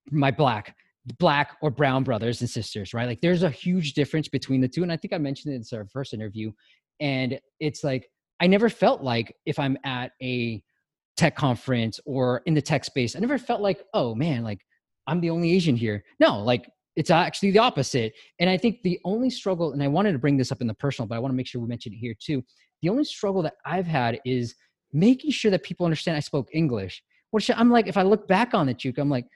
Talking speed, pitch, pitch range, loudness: 240 wpm, 145 Hz, 125-180 Hz, -25 LUFS